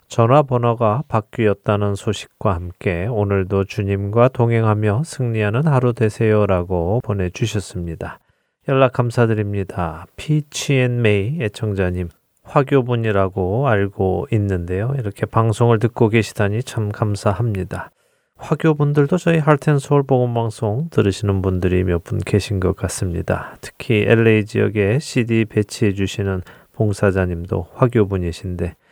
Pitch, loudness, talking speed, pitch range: 105 Hz, -19 LUFS, 305 characters per minute, 95-120 Hz